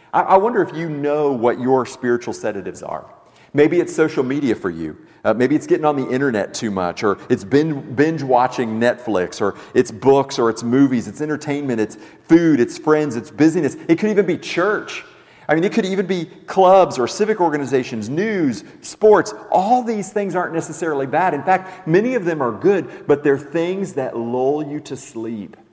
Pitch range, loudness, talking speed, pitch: 125-180 Hz, -18 LUFS, 195 wpm, 145 Hz